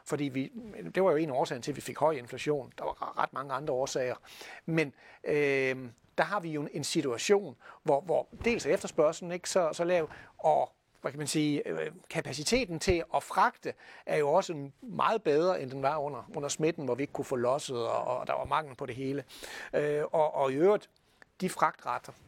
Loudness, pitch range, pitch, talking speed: -31 LUFS, 140-175 Hz, 150 Hz, 215 wpm